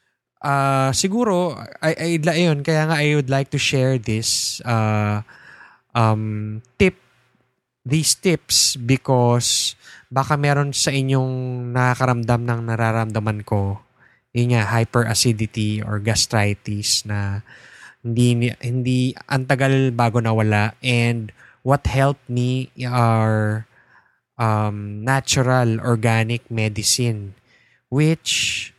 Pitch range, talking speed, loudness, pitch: 110-135 Hz, 100 wpm, -19 LUFS, 120 Hz